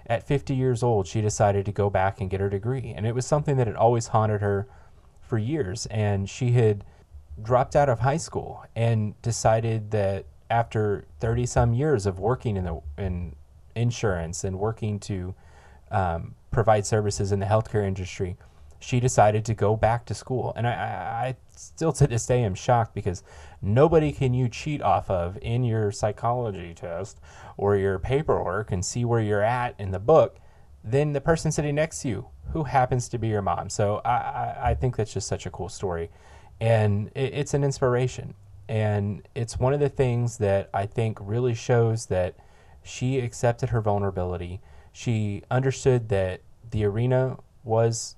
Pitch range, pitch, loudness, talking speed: 95-125 Hz, 110 Hz, -25 LUFS, 180 wpm